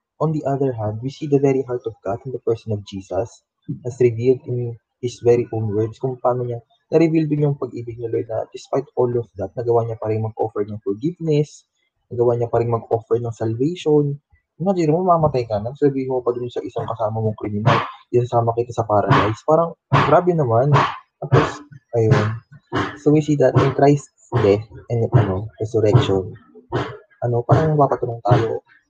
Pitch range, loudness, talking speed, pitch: 115-140 Hz, -20 LUFS, 185 wpm, 120 Hz